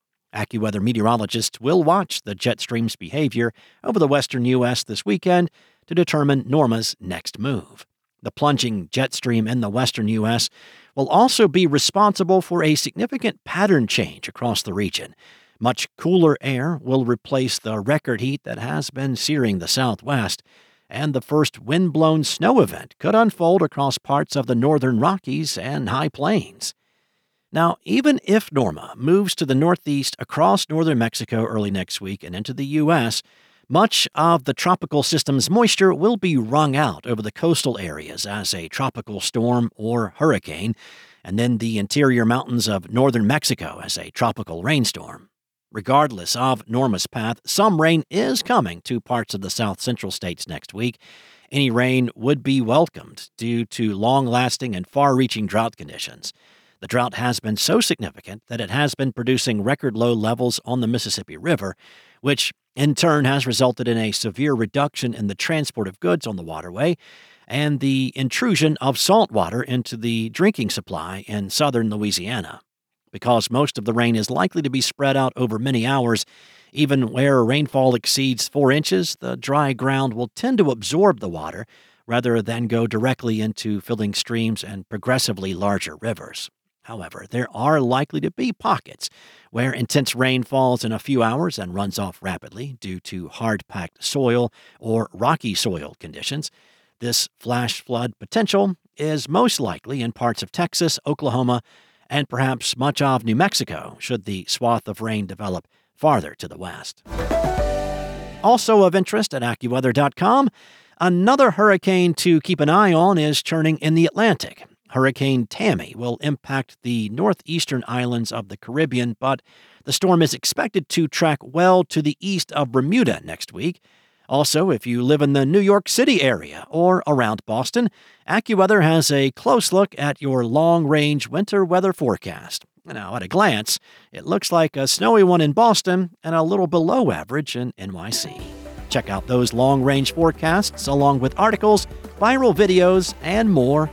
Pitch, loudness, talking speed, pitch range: 130 Hz, -20 LUFS, 165 wpm, 115-160 Hz